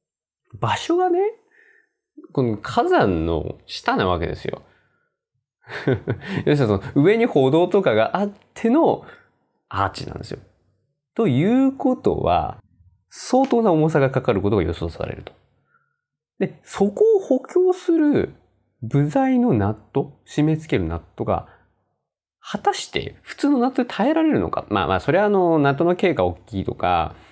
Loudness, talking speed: -20 LUFS, 270 characters per minute